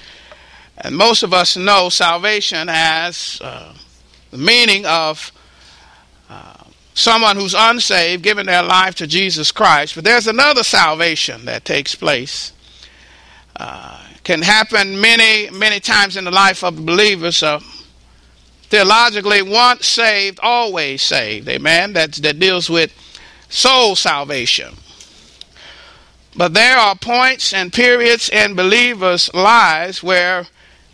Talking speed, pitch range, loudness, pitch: 125 wpm, 160-215 Hz, -12 LUFS, 185 Hz